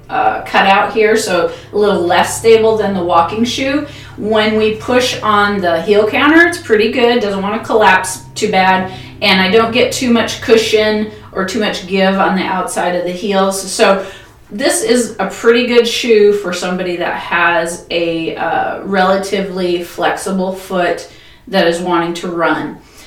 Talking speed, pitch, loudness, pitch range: 175 wpm, 195 Hz, -13 LUFS, 180-220 Hz